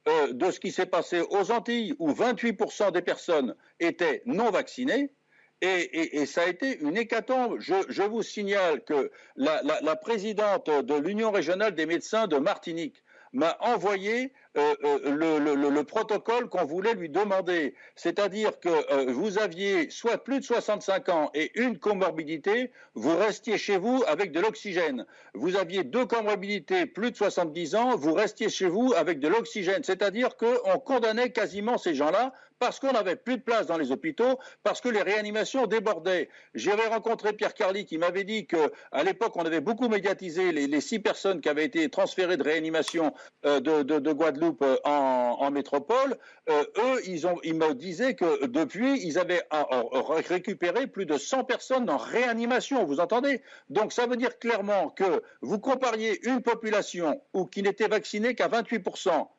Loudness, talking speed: -27 LUFS, 175 wpm